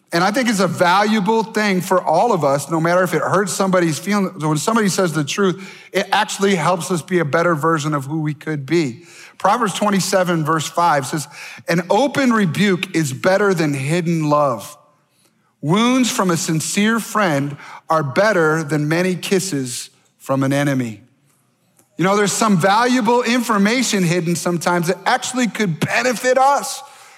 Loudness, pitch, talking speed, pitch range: -17 LUFS, 180 Hz, 165 wpm, 155-205 Hz